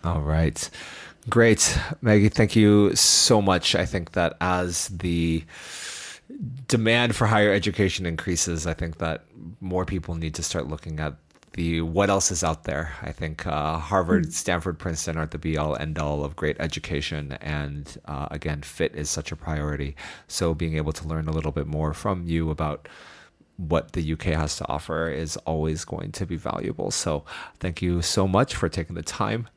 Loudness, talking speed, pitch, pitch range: -24 LUFS, 185 wpm, 80 Hz, 80-95 Hz